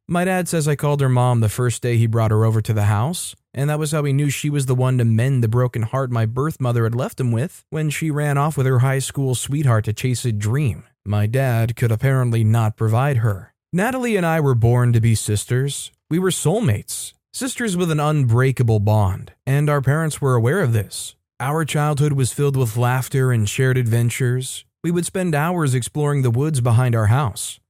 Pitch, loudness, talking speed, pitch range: 130 Hz, -19 LUFS, 220 wpm, 115-145 Hz